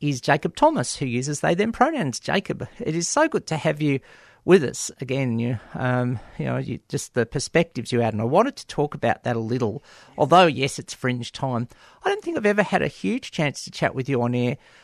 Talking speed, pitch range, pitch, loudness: 235 wpm, 125-180 Hz, 140 Hz, -23 LUFS